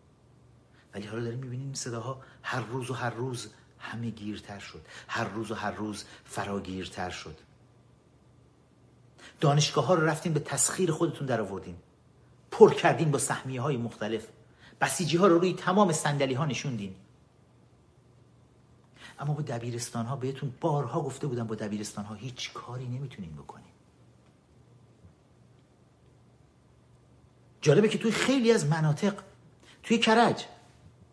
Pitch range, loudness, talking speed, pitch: 115-150 Hz, -29 LUFS, 130 wpm, 130 Hz